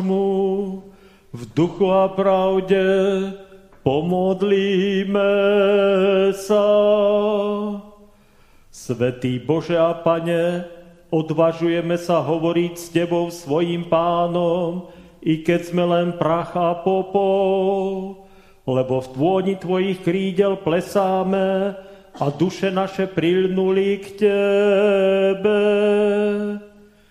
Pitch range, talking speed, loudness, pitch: 170-195 Hz, 80 wpm, -19 LUFS, 190 Hz